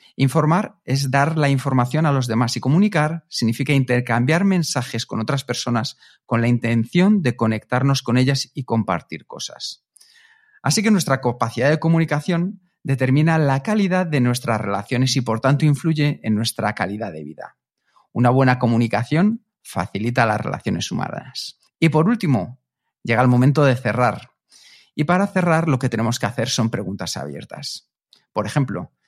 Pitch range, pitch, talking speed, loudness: 115-160 Hz, 130 Hz, 155 wpm, -20 LUFS